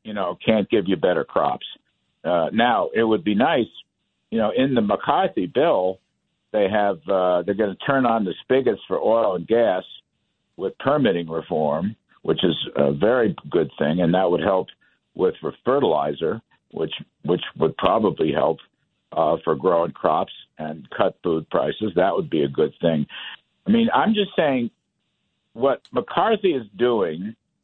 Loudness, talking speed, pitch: -22 LUFS, 165 wpm, 105 Hz